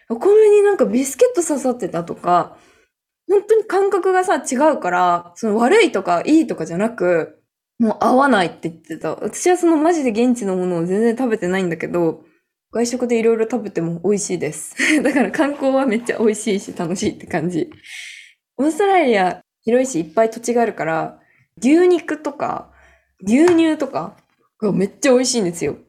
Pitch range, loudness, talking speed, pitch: 190-320 Hz, -17 LUFS, 370 characters per minute, 240 Hz